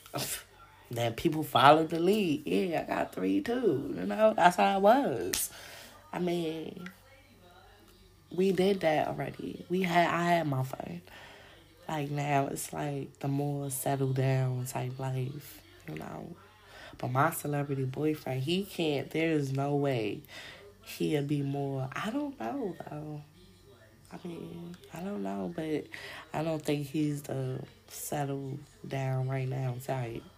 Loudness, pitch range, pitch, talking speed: -31 LUFS, 130-160 Hz, 140 Hz, 140 wpm